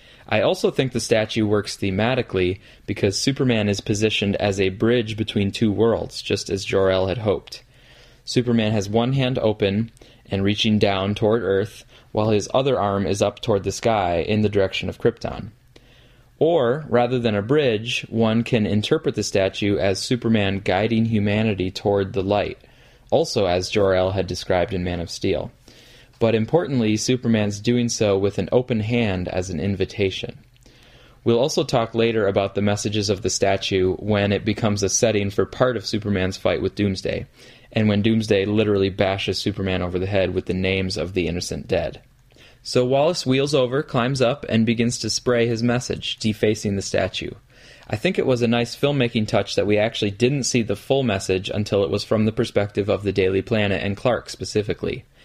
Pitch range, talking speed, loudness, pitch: 100-120 Hz, 180 wpm, -21 LUFS, 110 Hz